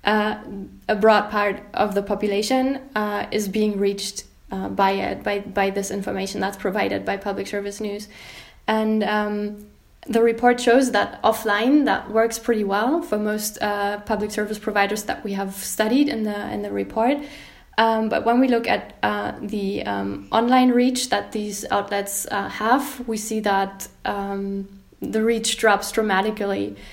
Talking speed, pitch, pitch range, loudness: 165 wpm, 210 Hz, 200-225 Hz, -22 LUFS